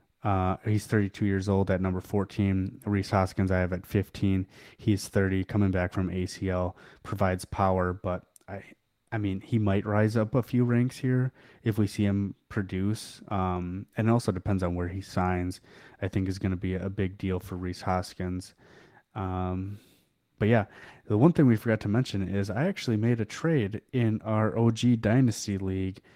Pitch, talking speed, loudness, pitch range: 100 Hz, 185 wpm, -28 LUFS, 95-110 Hz